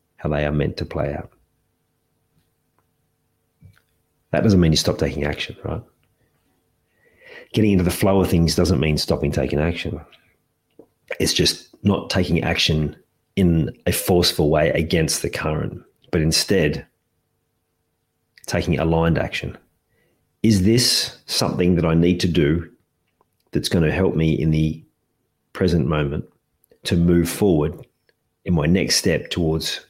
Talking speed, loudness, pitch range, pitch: 135 wpm, -20 LUFS, 80-90 Hz, 85 Hz